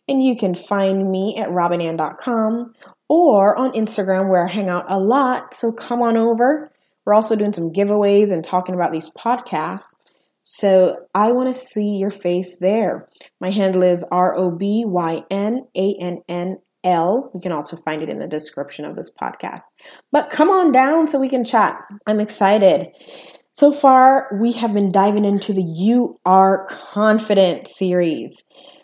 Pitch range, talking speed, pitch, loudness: 180-235 Hz, 155 wpm, 200 Hz, -17 LUFS